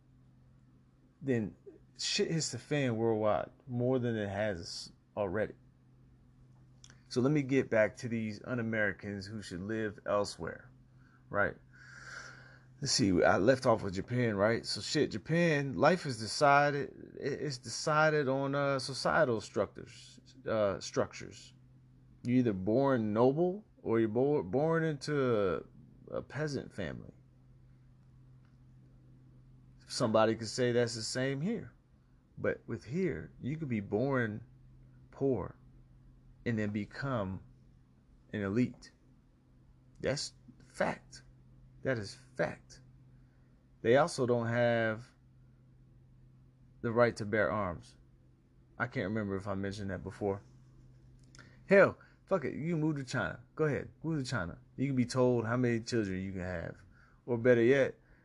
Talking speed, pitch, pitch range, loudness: 130 wpm, 125 Hz, 115-130 Hz, -33 LUFS